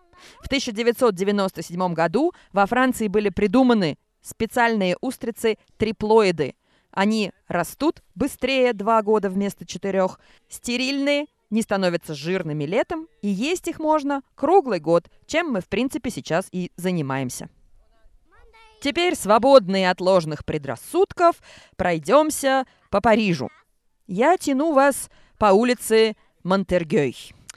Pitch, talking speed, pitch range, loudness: 220 Hz, 105 wpm, 185-275 Hz, -22 LUFS